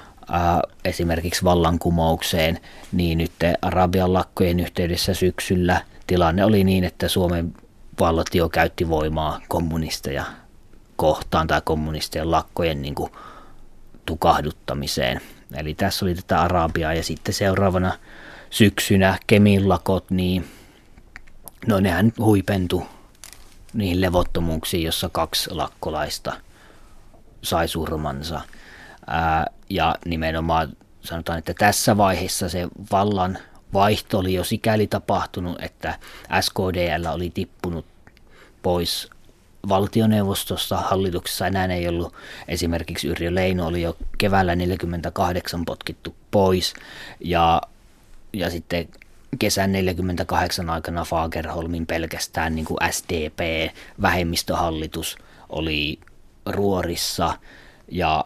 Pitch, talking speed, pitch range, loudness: 90 Hz, 95 wpm, 80-95 Hz, -22 LUFS